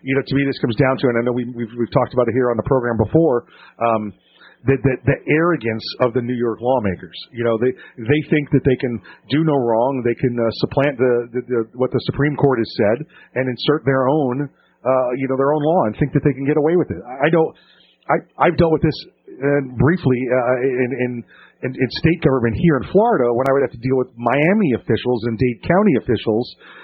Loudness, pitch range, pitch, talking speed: -18 LUFS, 120-145 Hz, 130 Hz, 230 wpm